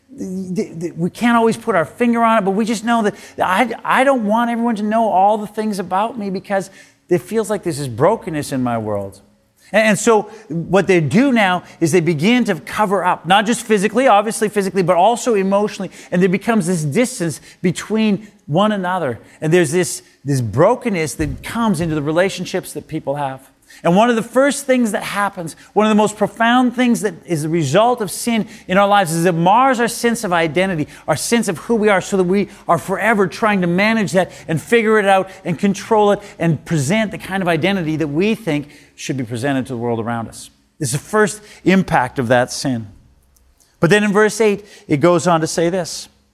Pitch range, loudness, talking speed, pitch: 165-215 Hz, -17 LUFS, 210 wpm, 190 Hz